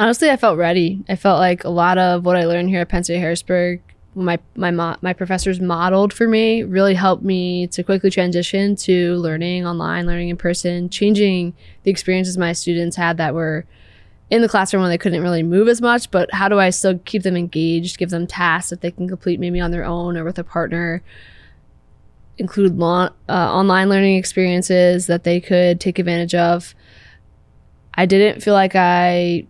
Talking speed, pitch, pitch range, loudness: 195 wpm, 180 Hz, 170-190 Hz, -17 LUFS